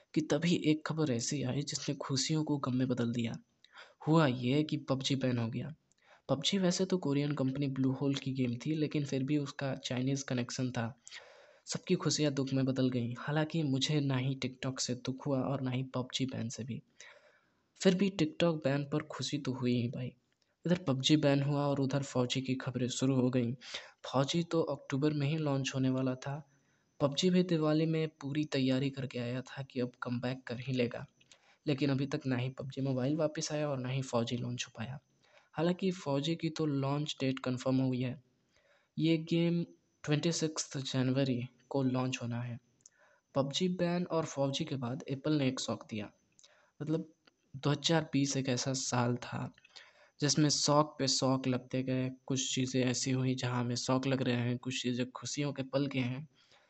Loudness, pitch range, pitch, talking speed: -34 LUFS, 130-150 Hz, 135 Hz, 185 wpm